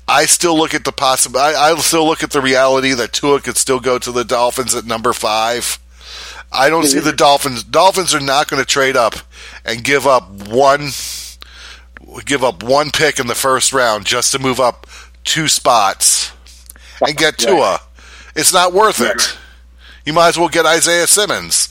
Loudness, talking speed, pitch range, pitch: -13 LUFS, 185 wpm, 100-145 Hz, 130 Hz